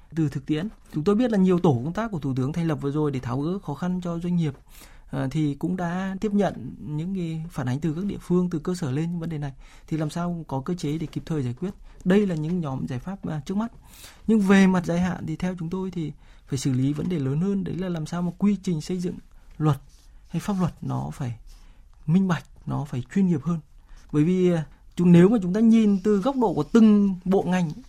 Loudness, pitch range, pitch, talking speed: -25 LUFS, 150-185 Hz, 170 Hz, 255 wpm